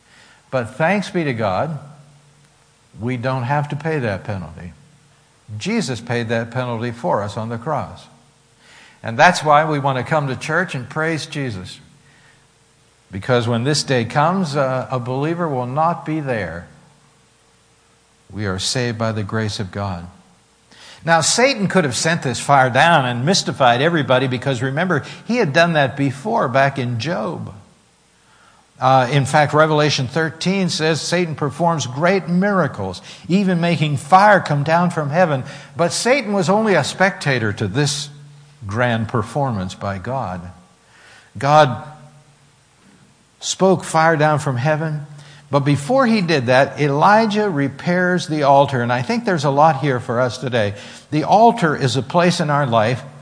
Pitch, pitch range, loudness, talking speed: 145 Hz, 125-160 Hz, -18 LUFS, 155 wpm